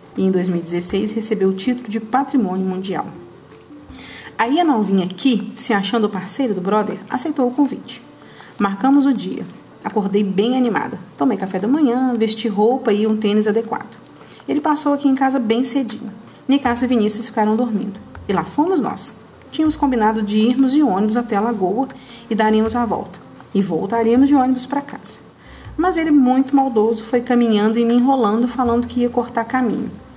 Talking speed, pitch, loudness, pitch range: 175 wpm, 235 Hz, -18 LUFS, 215-260 Hz